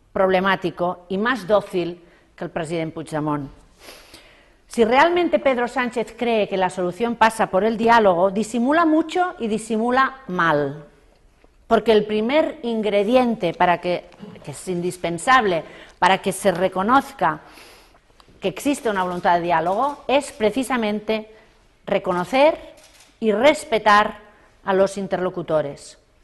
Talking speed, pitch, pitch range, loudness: 120 wpm, 210 Hz, 180-240 Hz, -20 LUFS